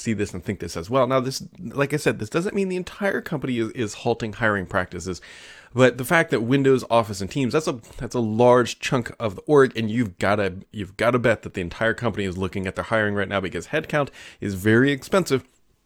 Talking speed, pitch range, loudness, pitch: 235 wpm, 100-135 Hz, -23 LUFS, 115 Hz